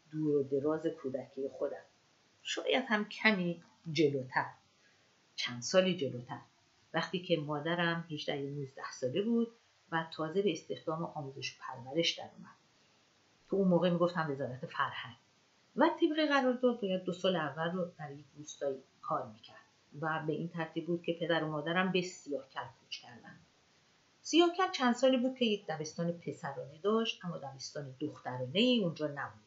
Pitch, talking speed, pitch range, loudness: 165 Hz, 160 wpm, 145-185 Hz, -34 LUFS